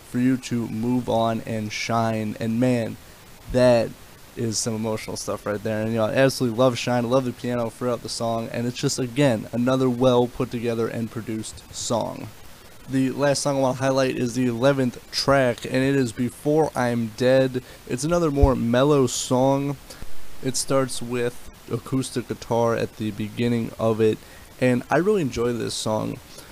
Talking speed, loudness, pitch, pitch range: 180 wpm, -23 LUFS, 120 Hz, 115-130 Hz